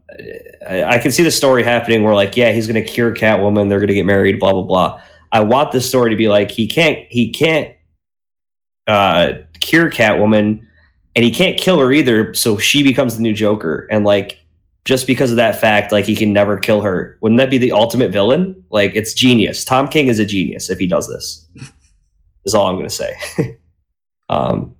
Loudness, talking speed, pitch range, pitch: -14 LUFS, 200 wpm, 100-130 Hz, 110 Hz